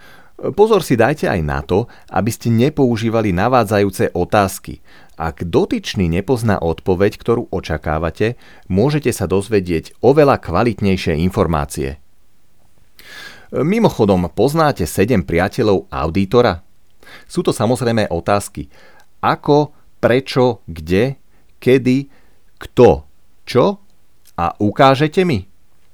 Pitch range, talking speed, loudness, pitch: 90-125 Hz, 95 wpm, -16 LUFS, 100 Hz